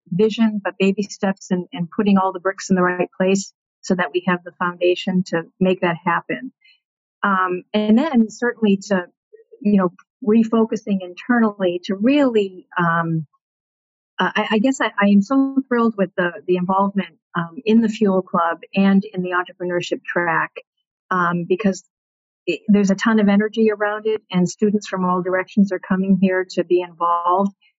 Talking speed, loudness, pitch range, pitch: 170 wpm, -19 LUFS, 180-215 Hz, 195 Hz